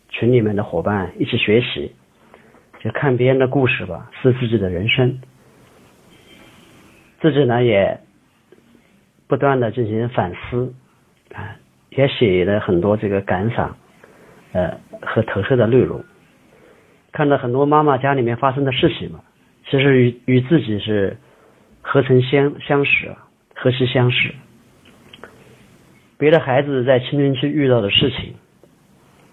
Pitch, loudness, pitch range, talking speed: 125 Hz, -17 LUFS, 115-140 Hz, 195 characters per minute